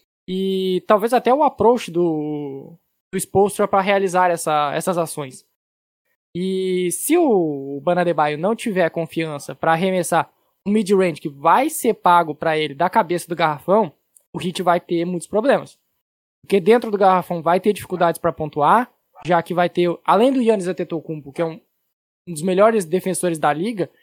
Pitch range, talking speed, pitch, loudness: 165-195 Hz, 170 wpm, 175 Hz, -19 LUFS